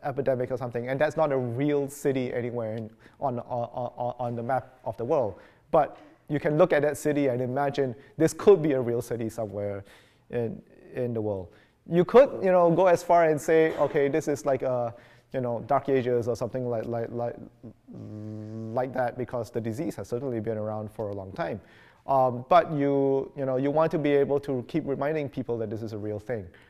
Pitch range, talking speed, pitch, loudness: 115-145 Hz, 215 wpm, 130 Hz, -27 LUFS